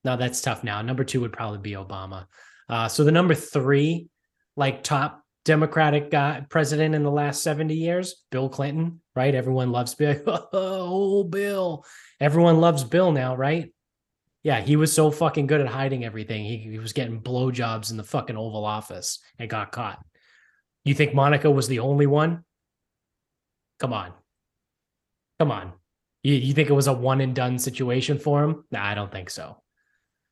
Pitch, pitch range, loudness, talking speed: 140 Hz, 125-155 Hz, -24 LUFS, 175 wpm